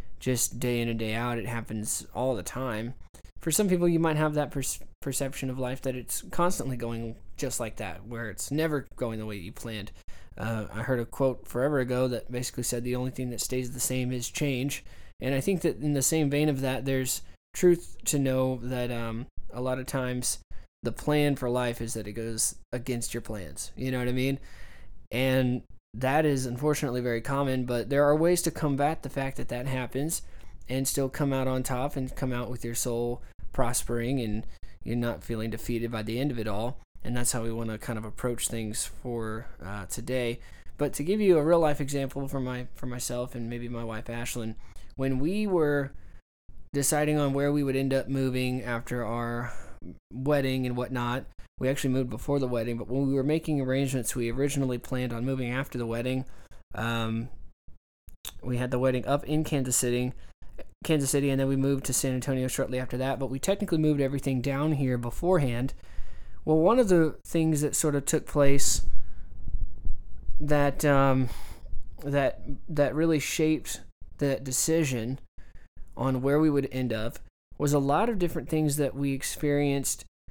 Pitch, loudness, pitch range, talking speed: 125 Hz, -29 LUFS, 115-140 Hz, 195 wpm